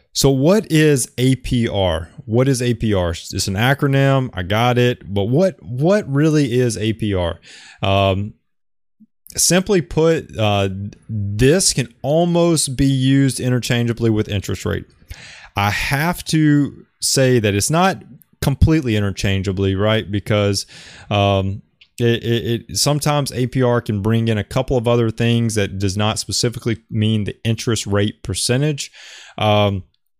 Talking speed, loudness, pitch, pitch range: 135 wpm, -18 LUFS, 115 Hz, 105-135 Hz